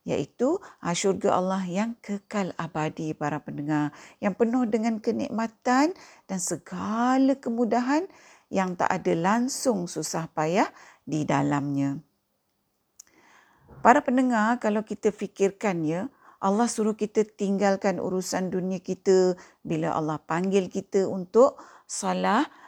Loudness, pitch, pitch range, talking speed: -26 LUFS, 200 Hz, 180-235 Hz, 110 wpm